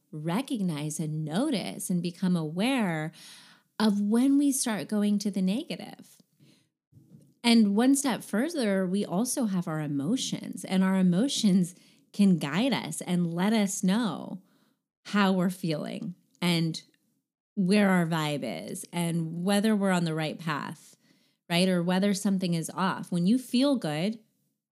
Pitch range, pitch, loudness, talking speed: 175-220 Hz, 195 Hz, -27 LUFS, 140 wpm